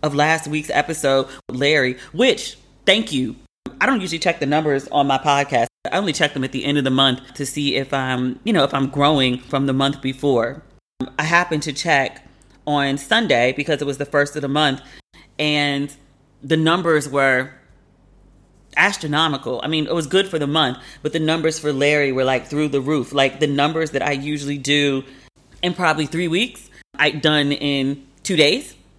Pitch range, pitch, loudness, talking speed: 135-155 Hz, 145 Hz, -19 LUFS, 190 wpm